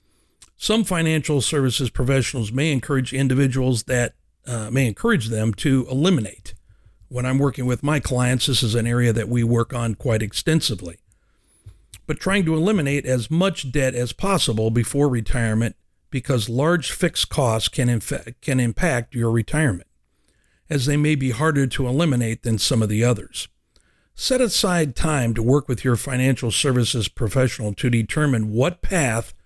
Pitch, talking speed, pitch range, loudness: 125 Hz, 155 wpm, 115-145 Hz, -21 LUFS